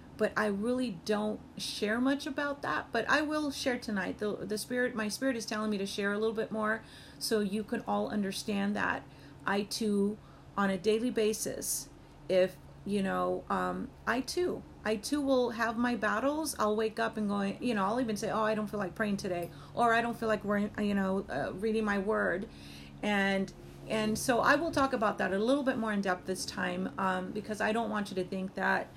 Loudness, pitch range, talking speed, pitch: -32 LUFS, 195-230 Hz, 215 wpm, 215 Hz